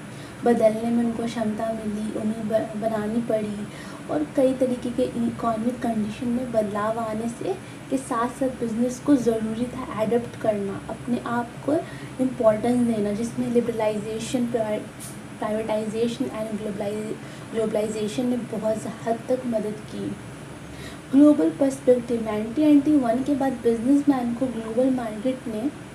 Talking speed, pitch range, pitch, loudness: 130 wpm, 220-255 Hz, 235 Hz, -24 LUFS